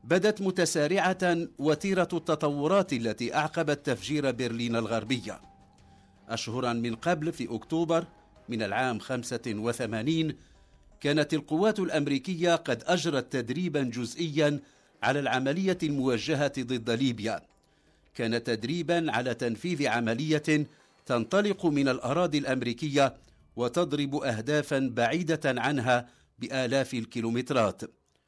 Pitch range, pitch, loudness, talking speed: 120-160 Hz, 135 Hz, -29 LUFS, 95 wpm